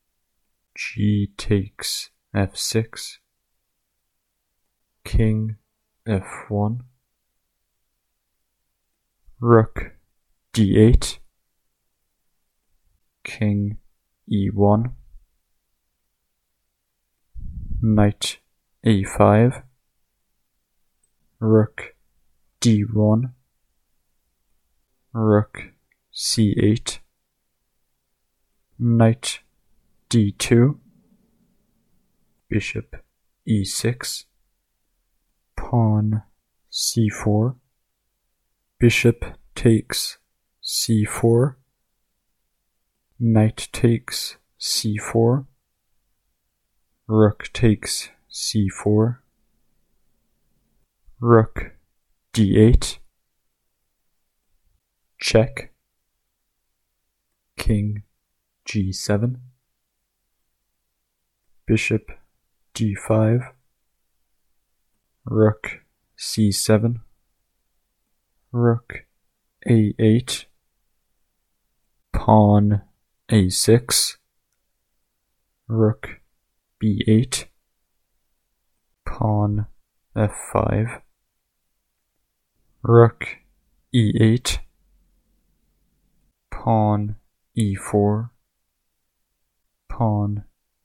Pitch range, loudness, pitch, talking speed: 100-115 Hz, -20 LUFS, 110 Hz, 45 wpm